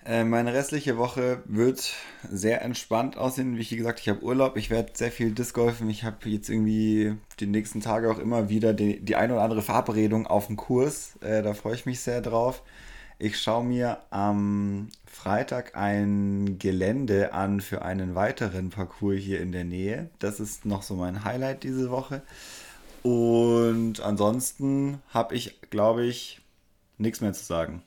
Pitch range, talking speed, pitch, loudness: 100-120 Hz, 165 wpm, 110 Hz, -27 LUFS